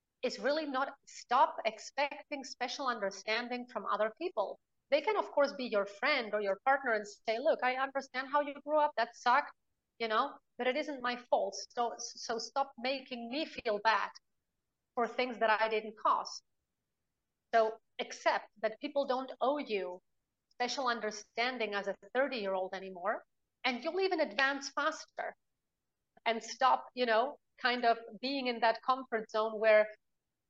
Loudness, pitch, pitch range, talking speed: -34 LUFS, 245 Hz, 220-275 Hz, 160 wpm